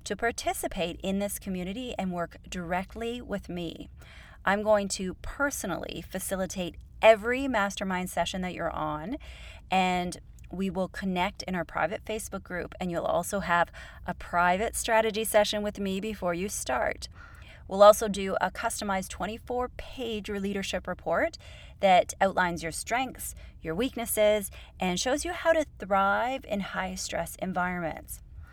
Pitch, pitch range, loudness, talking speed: 195 Hz, 180-220 Hz, -29 LUFS, 140 wpm